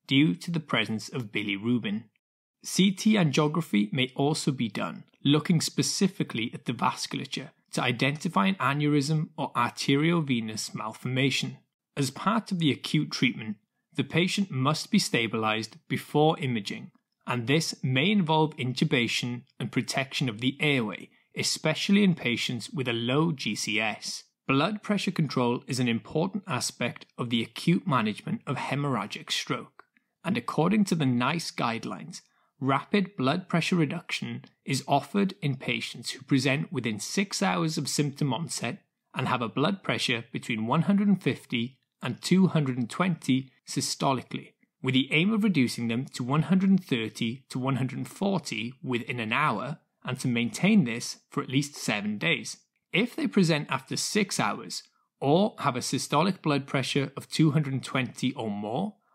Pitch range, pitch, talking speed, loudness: 125-175 Hz, 145 Hz, 140 wpm, -28 LUFS